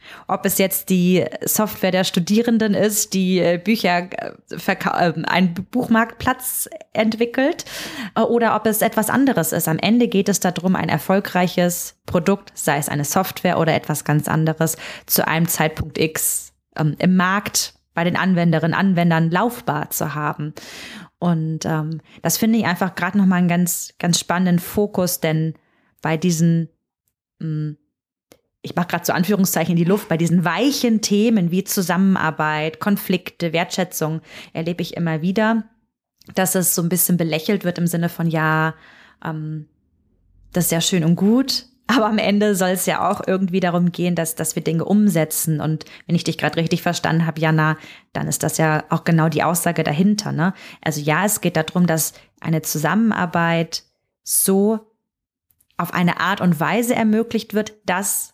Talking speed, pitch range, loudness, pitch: 160 wpm, 160-200 Hz, -19 LUFS, 175 Hz